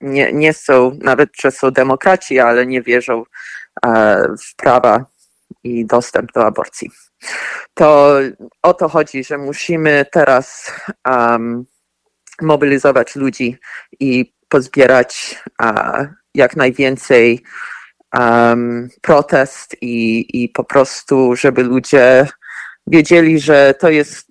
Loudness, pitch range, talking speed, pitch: -12 LUFS, 125-145 Hz, 105 wpm, 135 Hz